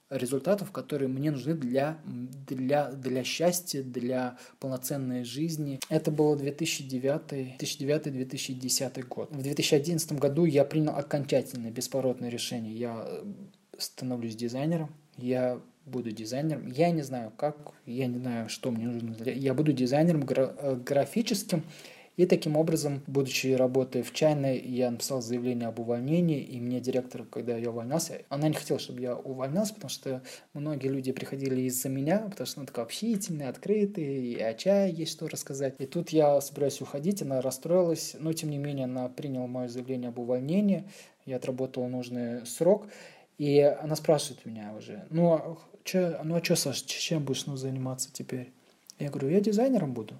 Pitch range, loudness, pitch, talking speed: 125-155 Hz, -30 LUFS, 140 Hz, 155 wpm